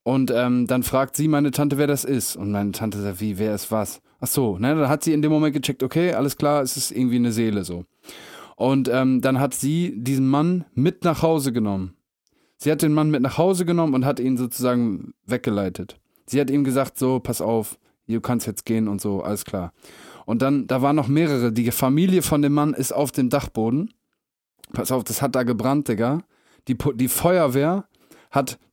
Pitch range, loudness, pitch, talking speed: 120-145 Hz, -22 LUFS, 130 Hz, 215 wpm